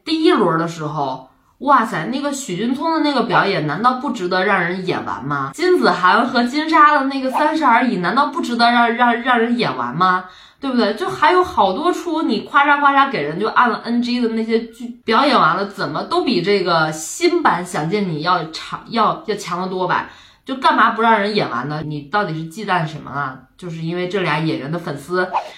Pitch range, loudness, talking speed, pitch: 175-275 Hz, -17 LUFS, 305 characters per minute, 220 Hz